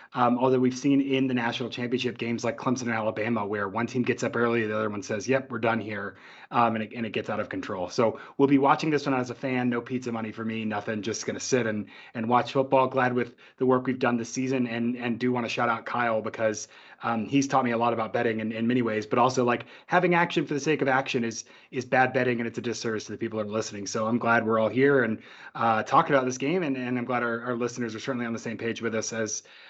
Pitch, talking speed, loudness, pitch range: 120 Hz, 280 wpm, -27 LUFS, 115-130 Hz